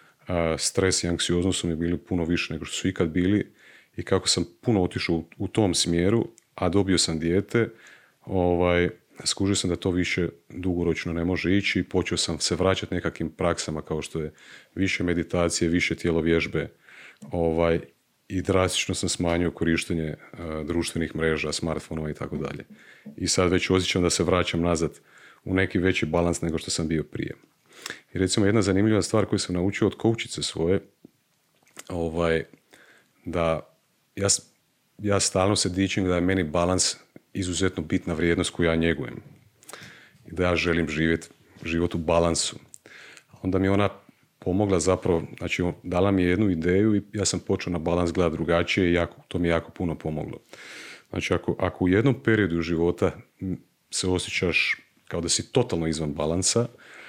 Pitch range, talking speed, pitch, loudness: 85-95 Hz, 165 wpm, 90 Hz, -25 LUFS